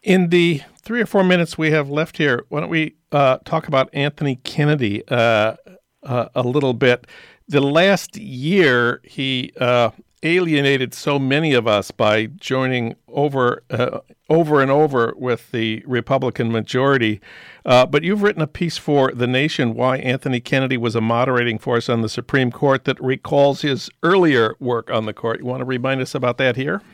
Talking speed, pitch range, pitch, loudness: 180 wpm, 120-150 Hz, 130 Hz, -18 LUFS